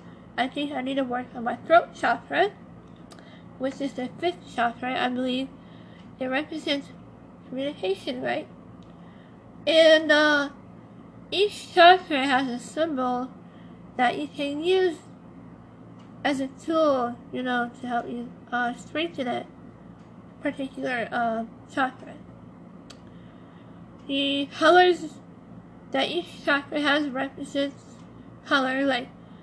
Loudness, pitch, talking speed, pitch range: -25 LUFS, 275 Hz, 110 wpm, 250-300 Hz